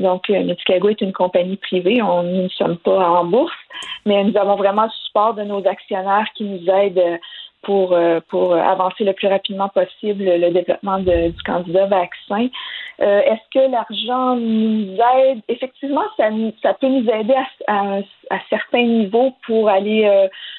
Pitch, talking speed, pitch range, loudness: 200 Hz, 170 wpm, 185-230 Hz, -17 LUFS